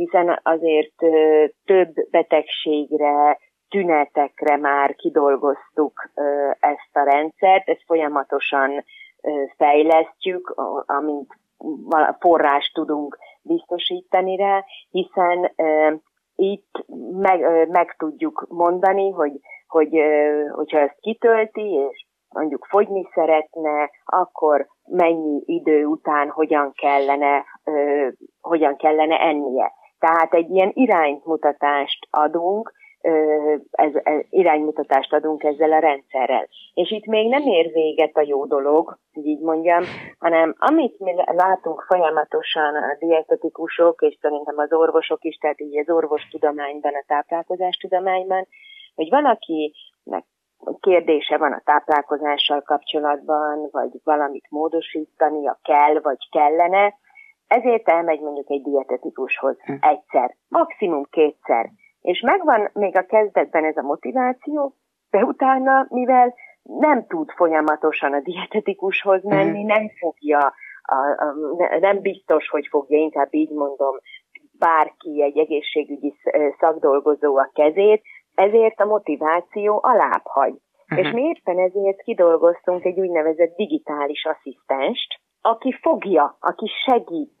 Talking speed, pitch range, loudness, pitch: 105 wpm, 150-190 Hz, -19 LUFS, 160 Hz